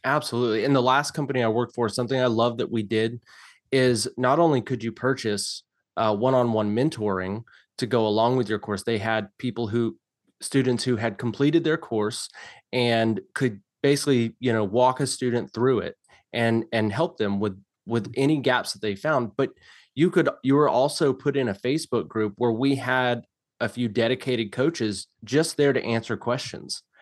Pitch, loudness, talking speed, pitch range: 120 Hz, -24 LUFS, 180 wpm, 110-130 Hz